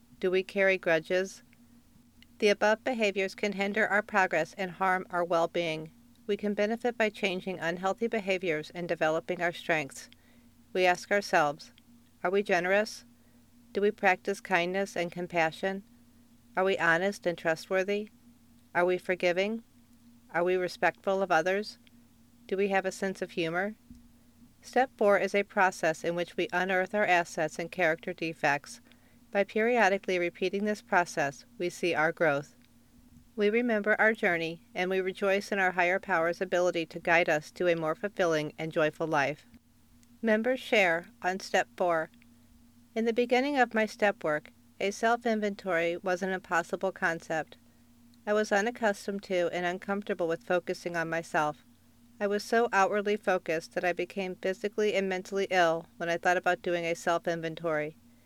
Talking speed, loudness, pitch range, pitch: 160 wpm, -29 LUFS, 165-200 Hz, 185 Hz